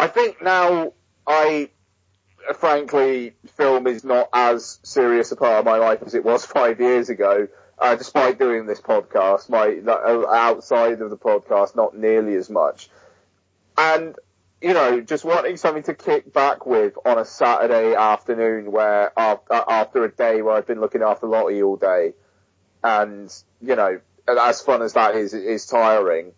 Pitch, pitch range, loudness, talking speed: 115 Hz, 105-145 Hz, -19 LUFS, 165 wpm